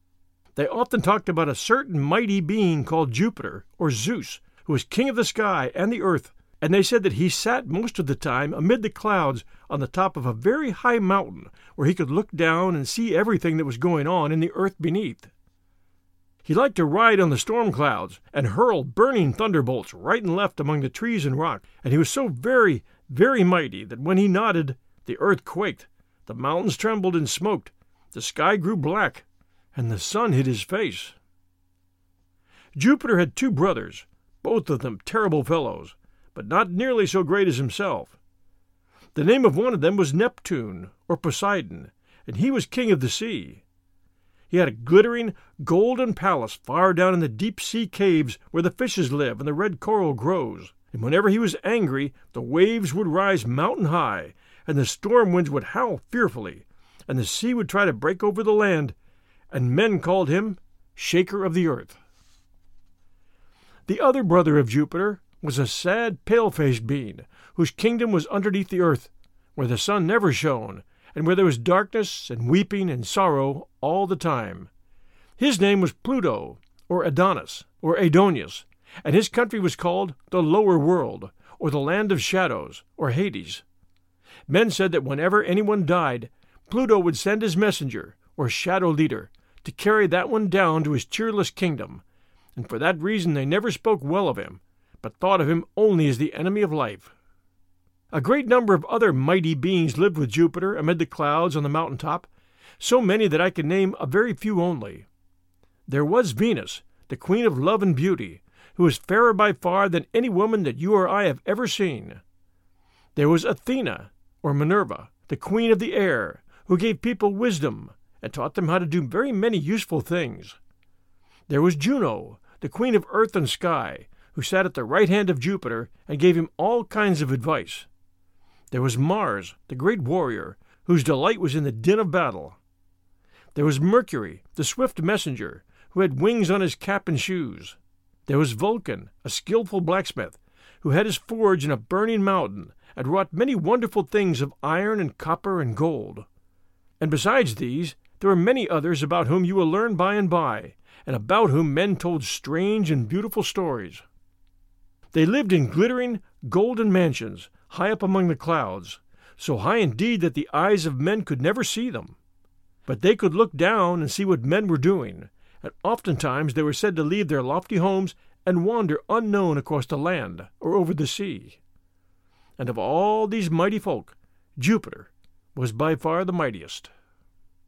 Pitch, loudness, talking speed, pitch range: 170 Hz, -23 LUFS, 180 wpm, 125-200 Hz